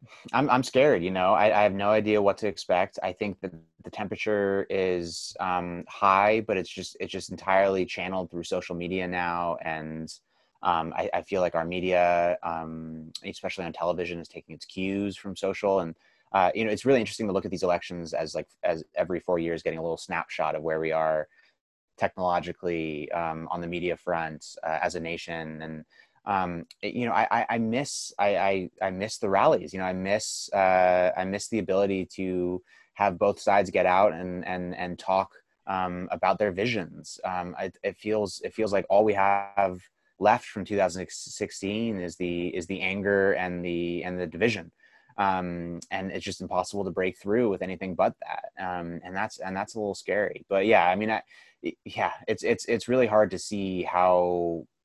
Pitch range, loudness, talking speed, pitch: 85-100 Hz, -27 LUFS, 200 wpm, 90 Hz